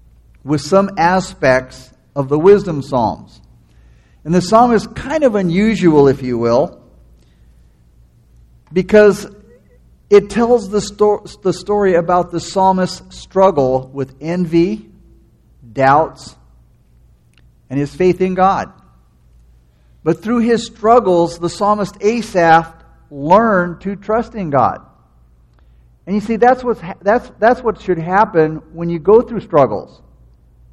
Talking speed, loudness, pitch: 125 wpm, -14 LUFS, 170 Hz